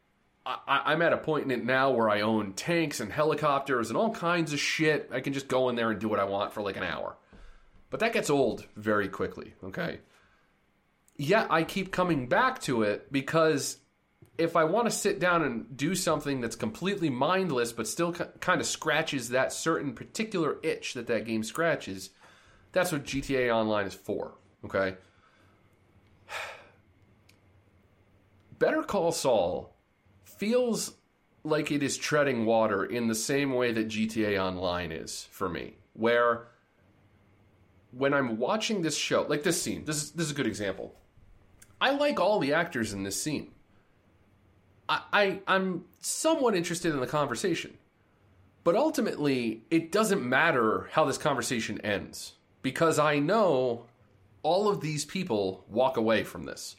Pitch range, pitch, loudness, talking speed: 105-165 Hz, 130 Hz, -29 LUFS, 160 wpm